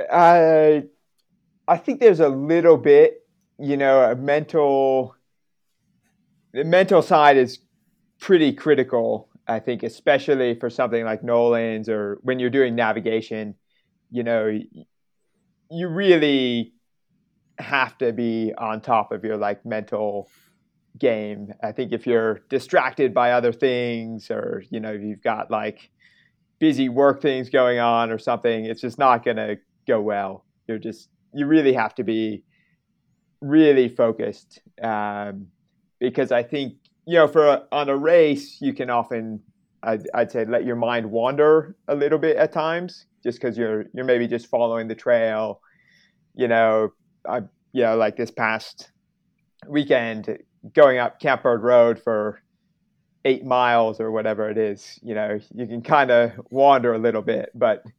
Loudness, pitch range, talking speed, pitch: -20 LUFS, 110-155 Hz, 150 wpm, 125 Hz